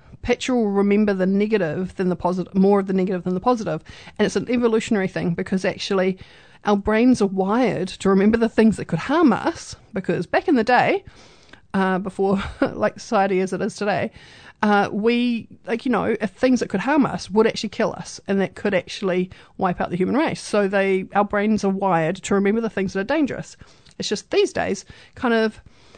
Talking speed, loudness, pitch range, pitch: 210 wpm, -21 LUFS, 190-225 Hz, 200 Hz